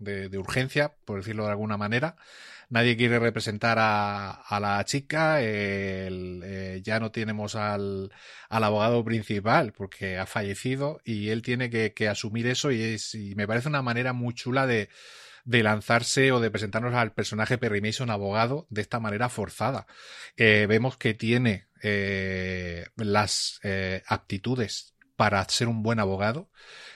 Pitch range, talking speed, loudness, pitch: 100-120 Hz, 160 wpm, -27 LUFS, 110 Hz